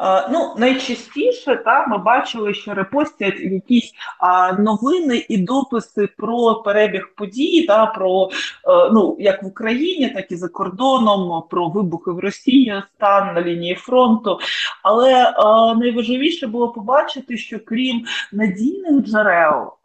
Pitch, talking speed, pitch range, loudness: 225 Hz, 120 wpm, 195-255 Hz, -17 LUFS